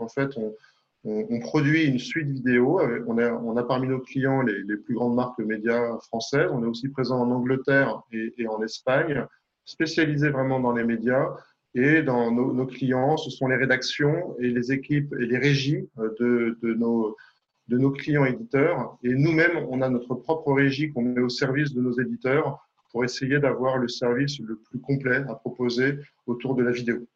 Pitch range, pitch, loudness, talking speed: 120-135 Hz, 125 Hz, -25 LUFS, 190 wpm